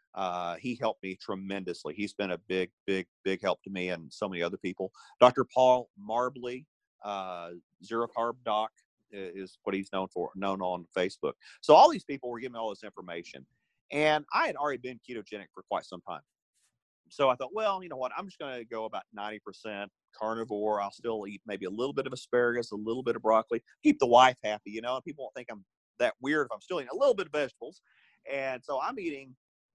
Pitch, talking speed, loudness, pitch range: 110 Hz, 220 wpm, -30 LUFS, 95-125 Hz